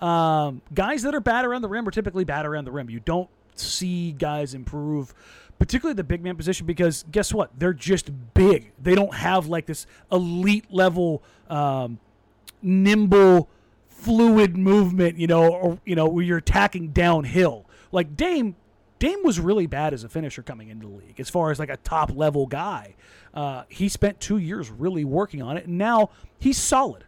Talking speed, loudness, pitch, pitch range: 185 wpm, -22 LUFS, 170 Hz, 145-195 Hz